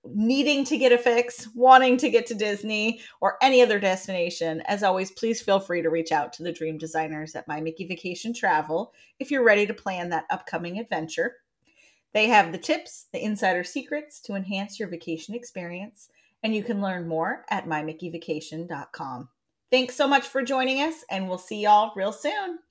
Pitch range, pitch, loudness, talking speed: 170-245 Hz, 205 Hz, -24 LUFS, 185 wpm